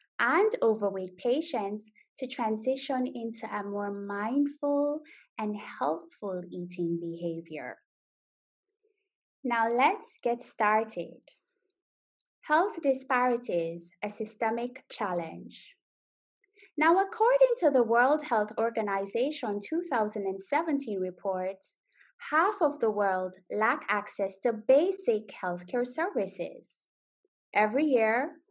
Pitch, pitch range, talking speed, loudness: 230 Hz, 200-290 Hz, 90 wpm, -29 LUFS